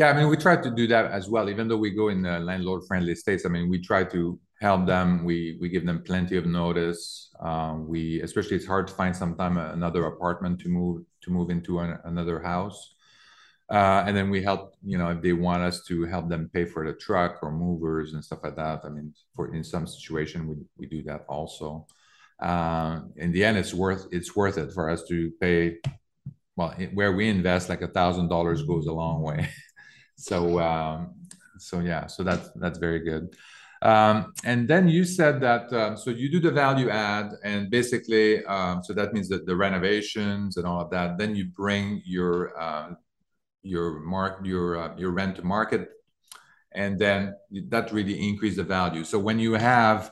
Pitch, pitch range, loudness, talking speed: 90 Hz, 85-100 Hz, -26 LUFS, 200 wpm